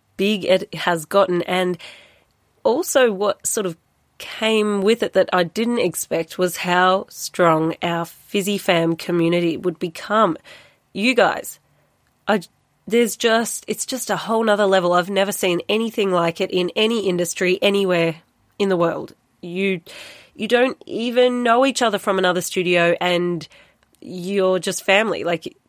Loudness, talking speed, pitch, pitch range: -19 LUFS, 150 wpm, 190 Hz, 175-215 Hz